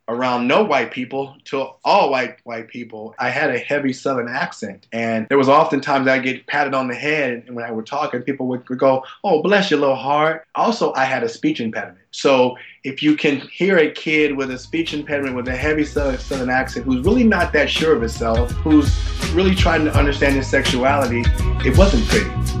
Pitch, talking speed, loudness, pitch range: 130 Hz, 210 wpm, -18 LUFS, 115-145 Hz